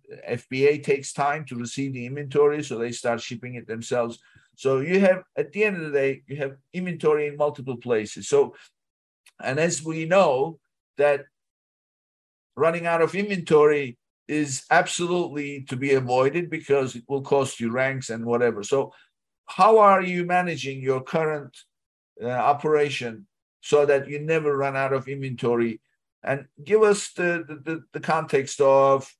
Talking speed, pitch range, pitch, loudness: 155 wpm, 130-160 Hz, 140 Hz, -23 LUFS